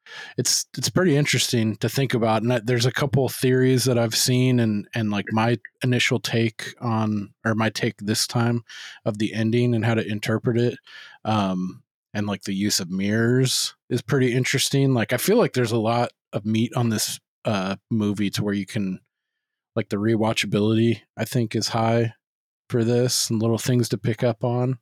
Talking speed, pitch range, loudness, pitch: 195 wpm, 110-125 Hz, -23 LUFS, 115 Hz